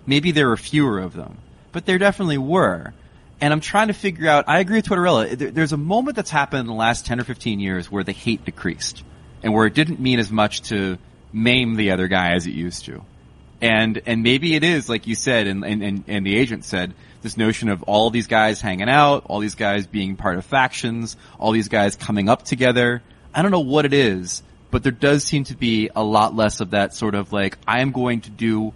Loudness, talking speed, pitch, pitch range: -19 LUFS, 240 wpm, 115 Hz, 100-140 Hz